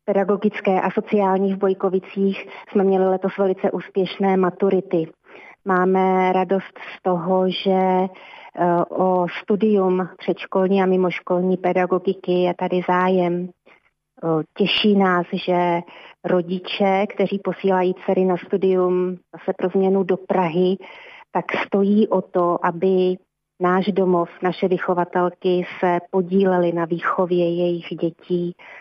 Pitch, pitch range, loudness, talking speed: 185 Hz, 180-195 Hz, -20 LUFS, 110 wpm